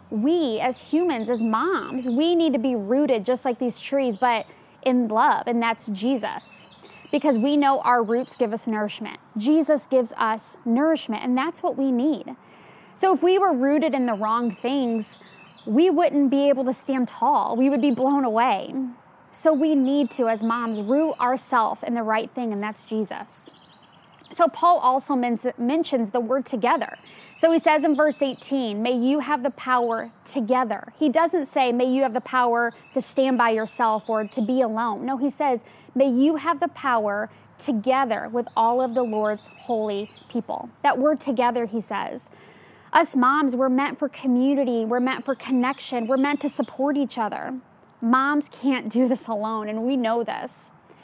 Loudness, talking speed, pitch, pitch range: -23 LUFS, 180 wpm, 255 Hz, 235-280 Hz